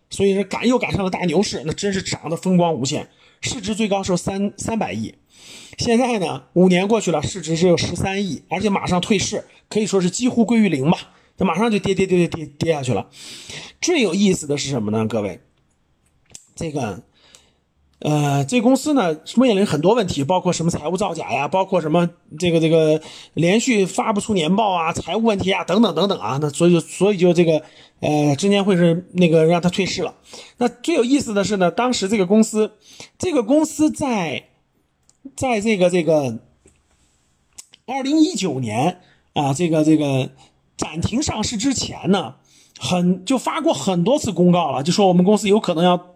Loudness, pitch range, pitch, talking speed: -19 LUFS, 155-215 Hz, 180 Hz, 280 characters per minute